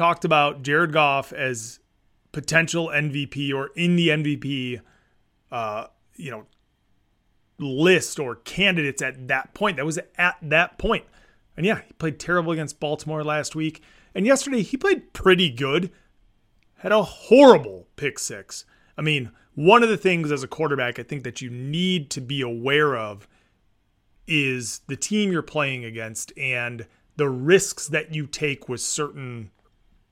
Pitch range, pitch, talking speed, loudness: 120-165 Hz, 145 Hz, 155 wpm, -22 LUFS